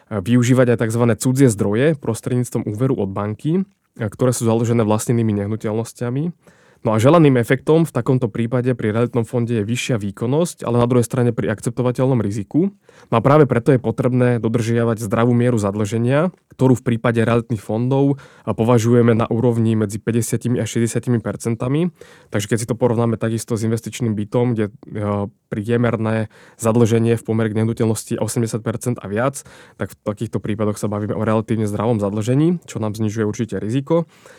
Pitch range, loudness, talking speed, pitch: 110-125 Hz, -19 LUFS, 155 wpm, 115 Hz